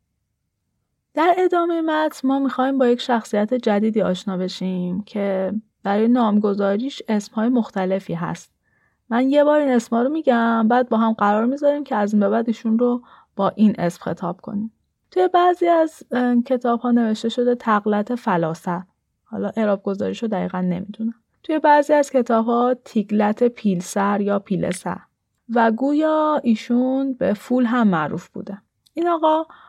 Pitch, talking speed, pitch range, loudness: 230 Hz, 150 wpm, 205-260 Hz, -20 LUFS